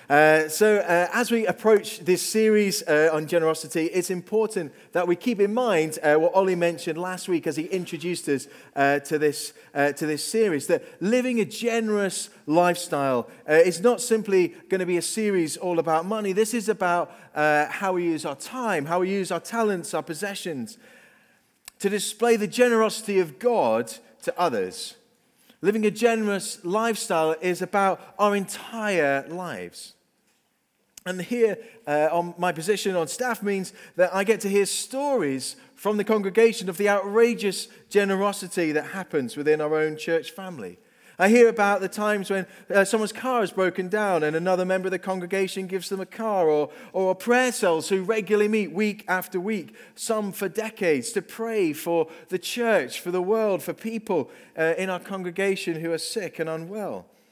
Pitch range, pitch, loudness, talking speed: 170-220 Hz, 195 Hz, -24 LUFS, 175 wpm